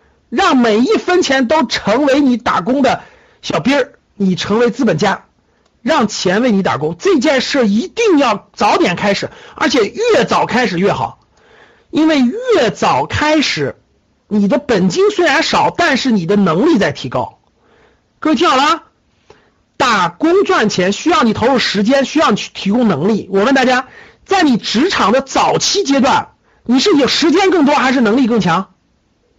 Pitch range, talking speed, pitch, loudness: 220-315 Hz, 240 characters per minute, 265 Hz, -13 LUFS